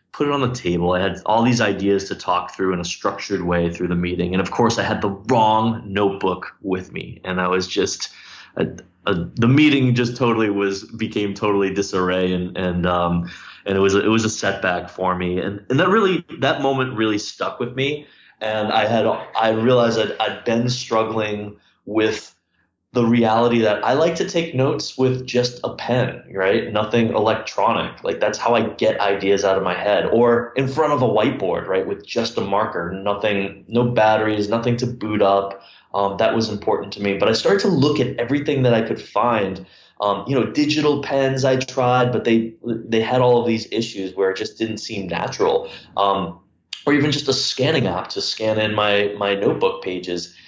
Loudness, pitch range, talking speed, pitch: -20 LUFS, 95-120 Hz, 205 wpm, 110 Hz